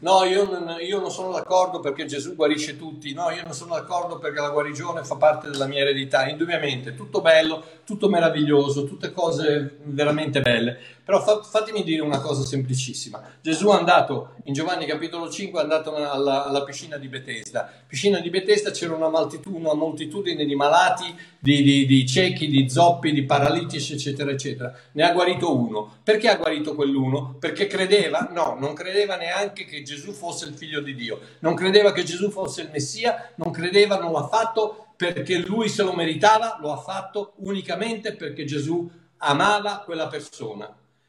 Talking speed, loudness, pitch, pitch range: 175 wpm, -22 LUFS, 160 Hz, 145-190 Hz